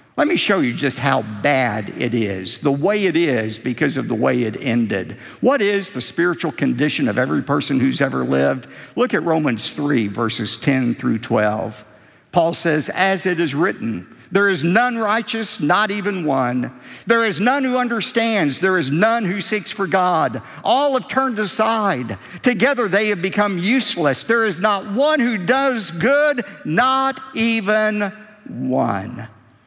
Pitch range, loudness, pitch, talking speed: 135-225 Hz, -18 LUFS, 190 Hz, 165 wpm